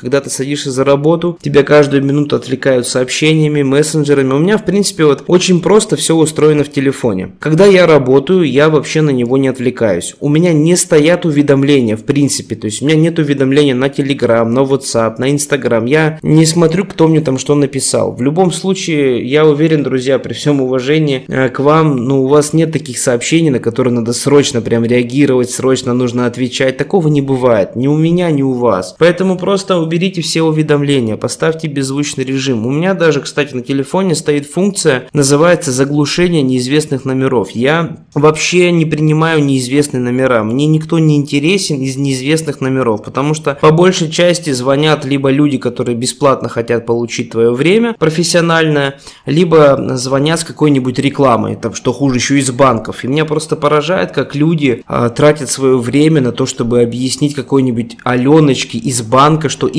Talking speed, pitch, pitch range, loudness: 175 wpm, 140 Hz, 130-155 Hz, -12 LUFS